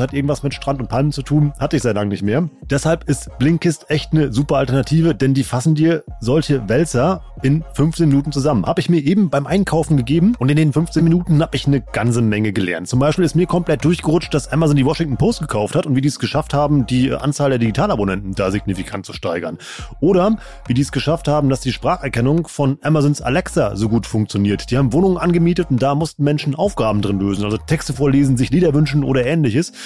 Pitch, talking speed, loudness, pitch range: 145 Hz, 220 wpm, -17 LUFS, 125-160 Hz